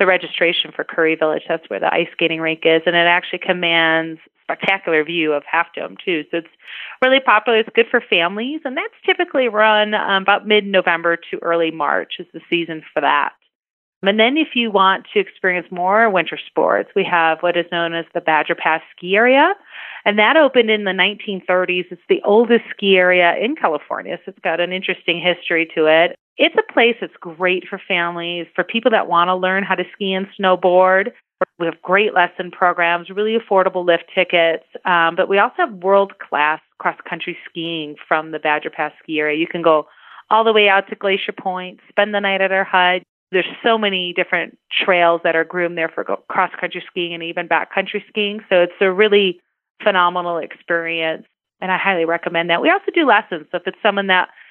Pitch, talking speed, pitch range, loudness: 180 Hz, 195 wpm, 170-200 Hz, -17 LUFS